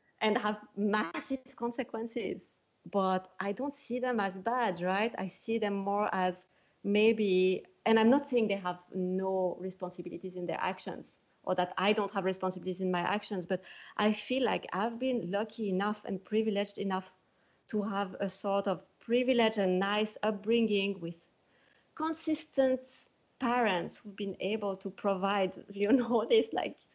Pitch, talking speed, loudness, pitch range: 205 Hz, 155 wpm, -32 LUFS, 190-230 Hz